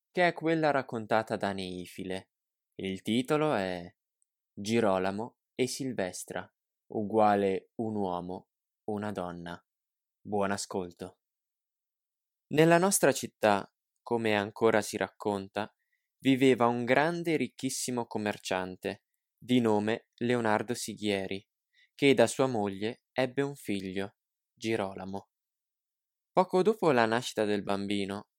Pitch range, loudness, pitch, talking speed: 100-130 Hz, -30 LUFS, 110 Hz, 105 wpm